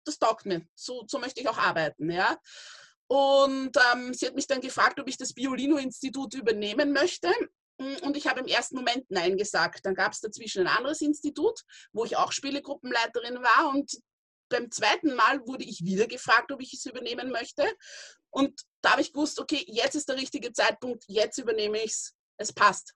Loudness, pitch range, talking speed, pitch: -27 LUFS, 240-295 Hz, 190 wpm, 270 Hz